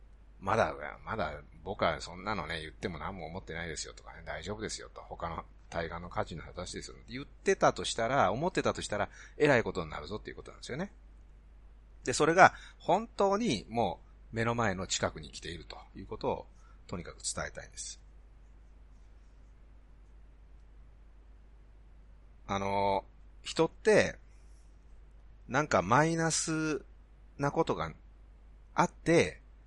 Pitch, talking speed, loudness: 100 Hz, 285 characters per minute, -32 LUFS